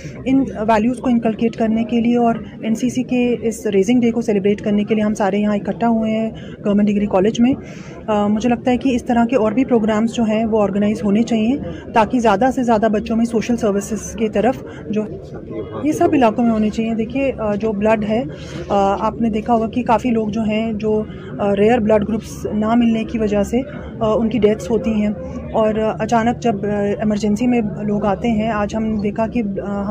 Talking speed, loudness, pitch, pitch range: 205 wpm, -18 LUFS, 220 Hz, 210-235 Hz